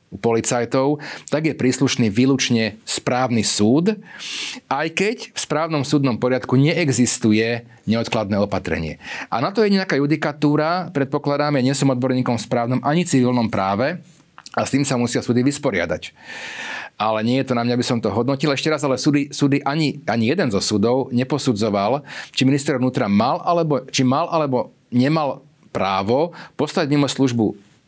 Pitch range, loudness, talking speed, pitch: 120-150 Hz, -19 LUFS, 160 wpm, 135 Hz